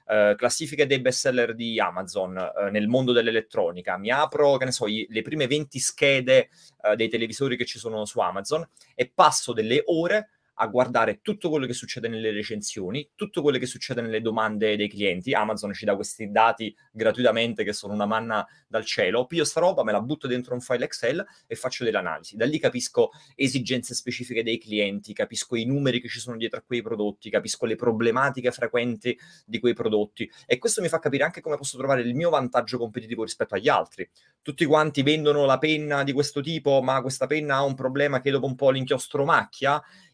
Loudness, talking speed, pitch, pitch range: -25 LUFS, 200 wpm, 125 Hz, 115-145 Hz